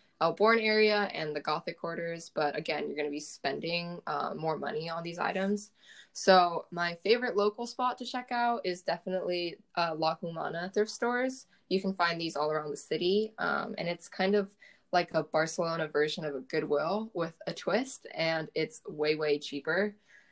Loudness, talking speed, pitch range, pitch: -31 LUFS, 185 wpm, 160-205 Hz, 175 Hz